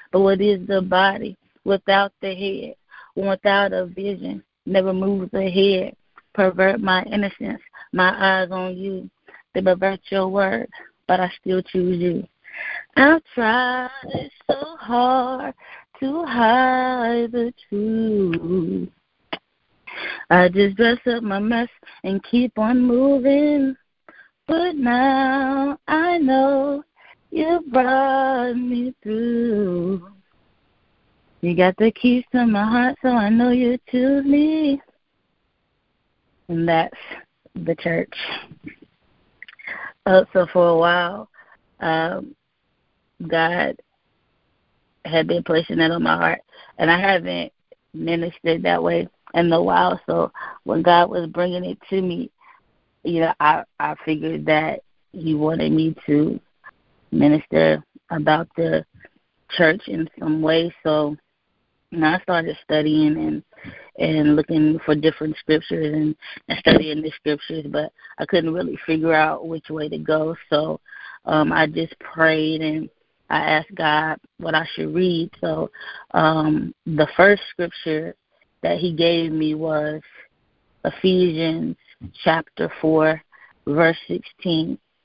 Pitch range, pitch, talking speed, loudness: 160-235 Hz, 185 Hz, 125 wpm, -20 LUFS